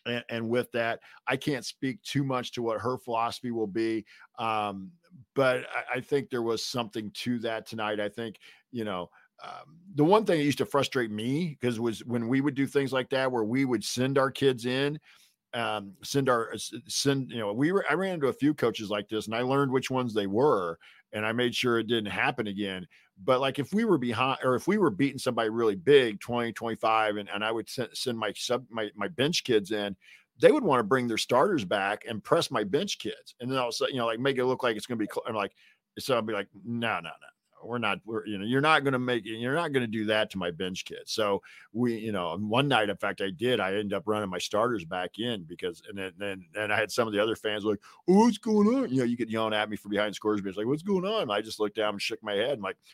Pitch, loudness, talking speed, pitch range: 120 Hz, -29 LUFS, 265 wpm, 105-135 Hz